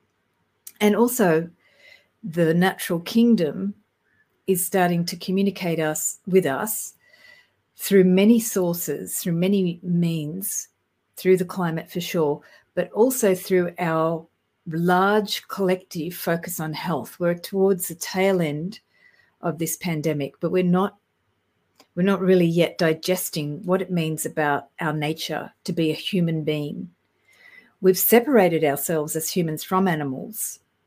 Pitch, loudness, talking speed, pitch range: 180 Hz, -22 LUFS, 130 wpm, 160-190 Hz